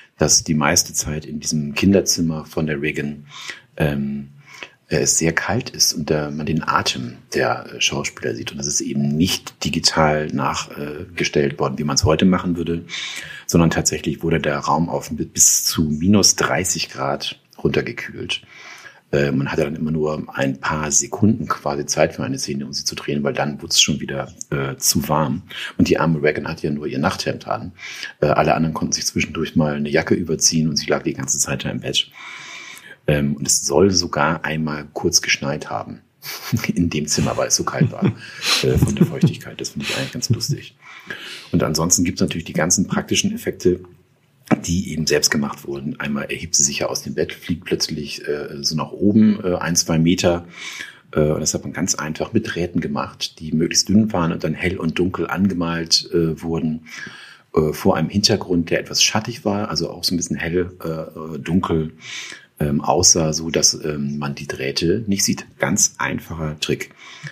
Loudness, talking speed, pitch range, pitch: -19 LUFS, 190 wpm, 75-85 Hz, 80 Hz